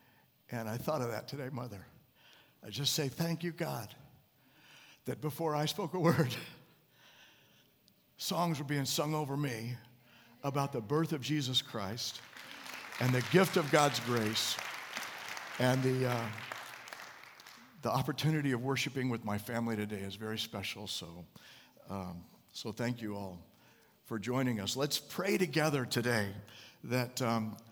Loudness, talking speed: -35 LUFS, 145 wpm